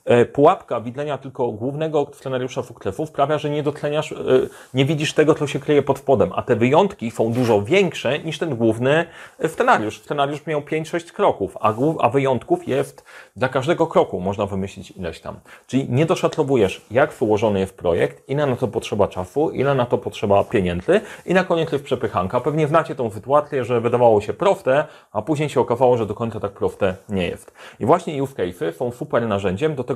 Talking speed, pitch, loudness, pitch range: 180 wpm, 135 Hz, -20 LUFS, 120-155 Hz